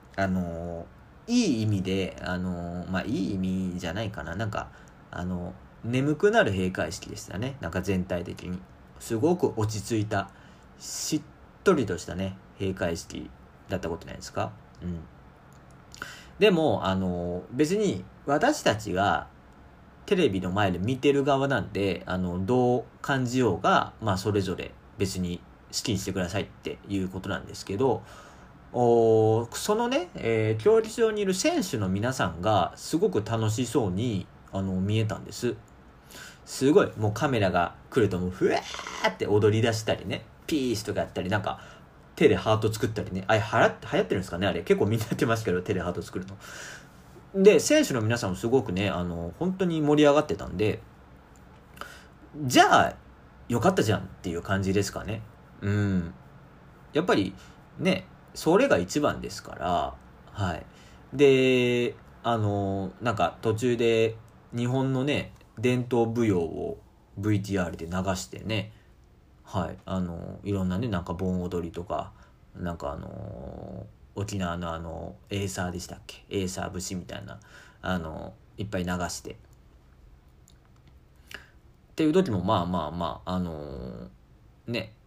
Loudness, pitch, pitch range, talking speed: -27 LUFS, 95 Hz, 90-115 Hz, 295 characters per minute